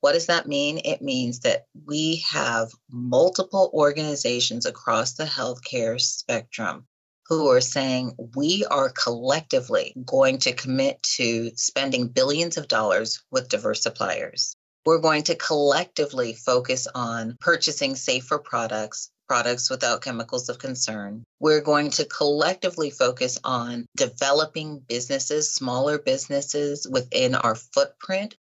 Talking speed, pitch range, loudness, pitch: 125 wpm, 125-160 Hz, -23 LUFS, 140 Hz